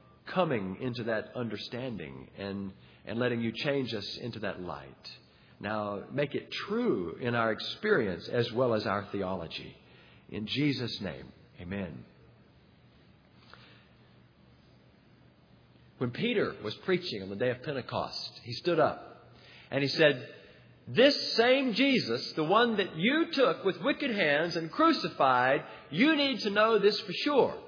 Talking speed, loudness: 140 wpm, -30 LUFS